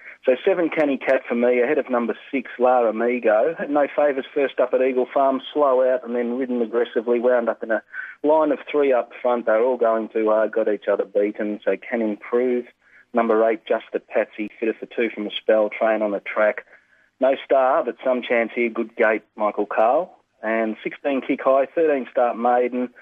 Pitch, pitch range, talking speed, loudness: 120 Hz, 110-130 Hz, 205 wpm, -21 LUFS